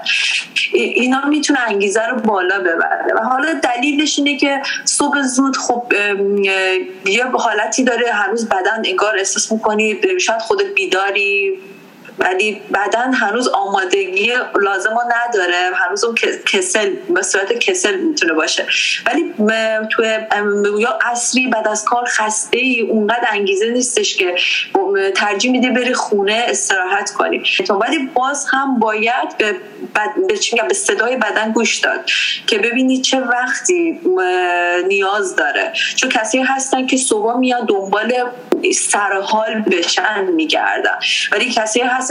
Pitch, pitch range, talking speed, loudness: 250 Hz, 215-345 Hz, 130 wpm, -15 LUFS